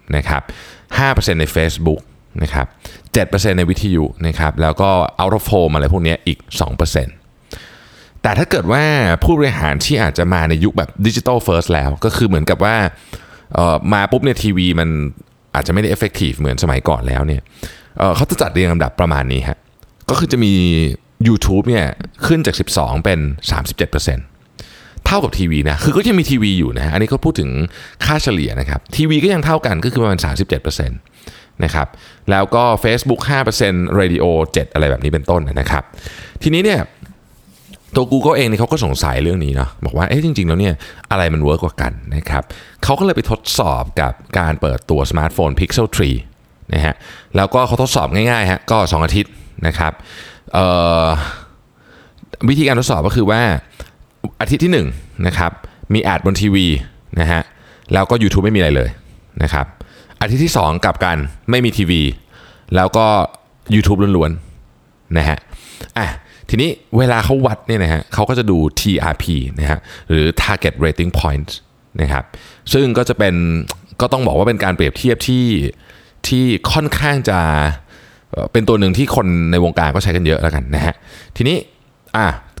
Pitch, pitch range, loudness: 90 Hz, 80-110 Hz, -15 LUFS